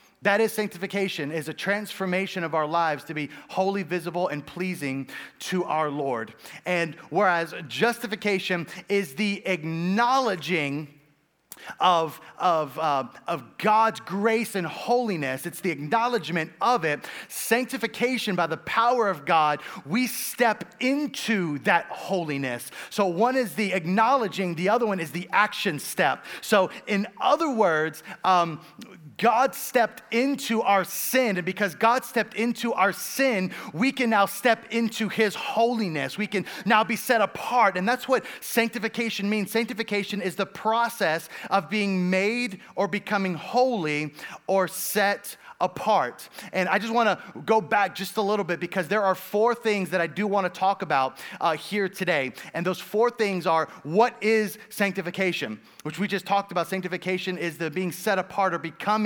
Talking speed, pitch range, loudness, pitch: 155 wpm, 175-225 Hz, -25 LUFS, 195 Hz